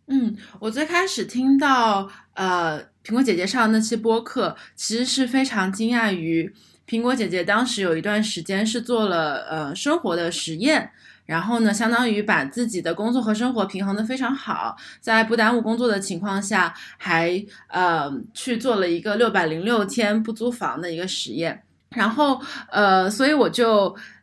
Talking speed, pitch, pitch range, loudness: 260 characters per minute, 215 Hz, 185-240 Hz, -22 LUFS